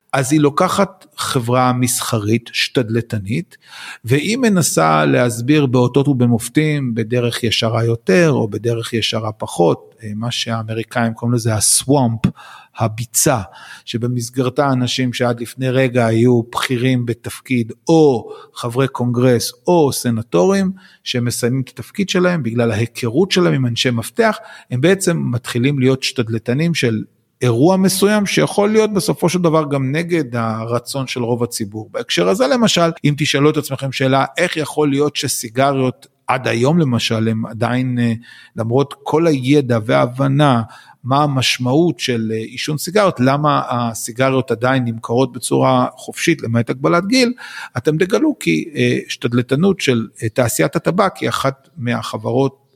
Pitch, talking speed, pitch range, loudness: 125 Hz, 125 wpm, 120-150 Hz, -16 LUFS